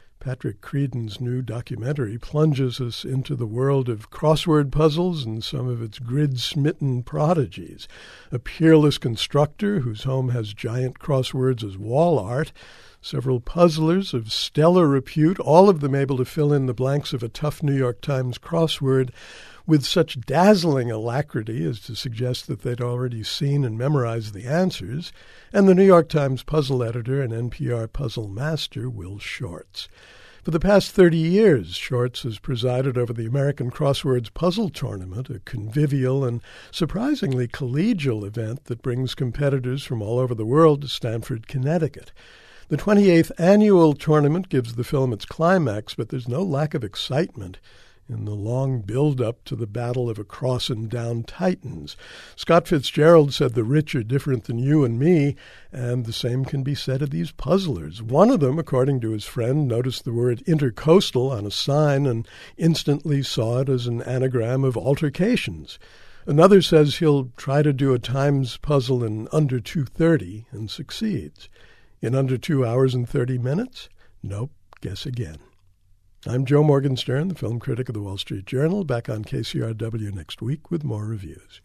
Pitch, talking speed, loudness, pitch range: 130 Hz, 165 wpm, -22 LUFS, 120-150 Hz